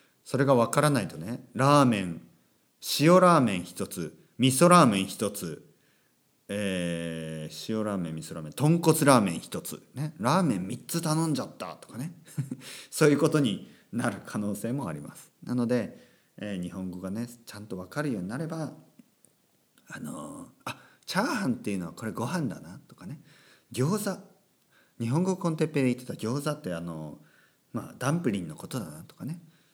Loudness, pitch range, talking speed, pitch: -27 LUFS, 95-155 Hz, 330 characters per minute, 125 Hz